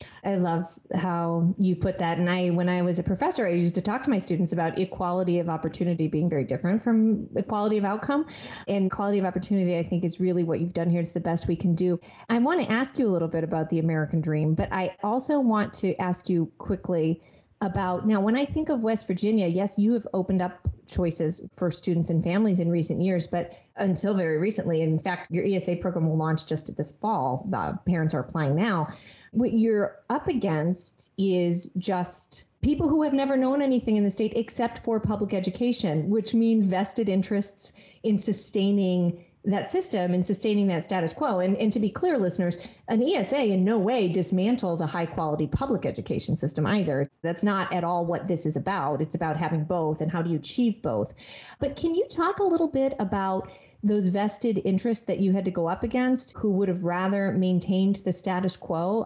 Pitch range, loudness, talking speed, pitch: 175-210 Hz, -26 LUFS, 205 wpm, 185 Hz